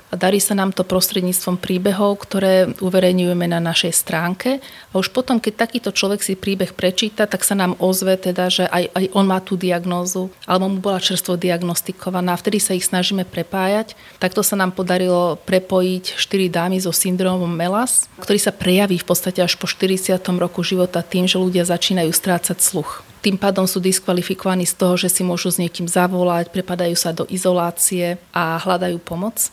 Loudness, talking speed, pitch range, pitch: -18 LUFS, 180 wpm, 180-190 Hz, 185 Hz